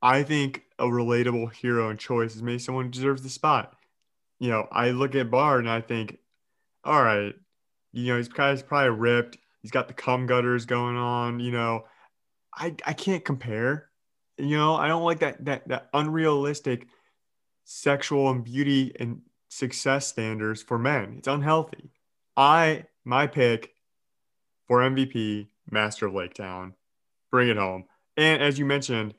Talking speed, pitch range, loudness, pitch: 160 wpm, 120-140 Hz, -25 LUFS, 125 Hz